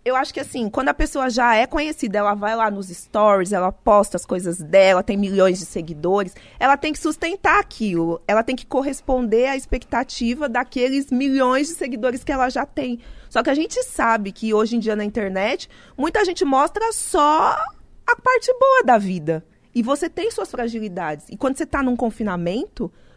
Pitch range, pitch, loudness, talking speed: 205-290 Hz, 250 Hz, -20 LUFS, 190 wpm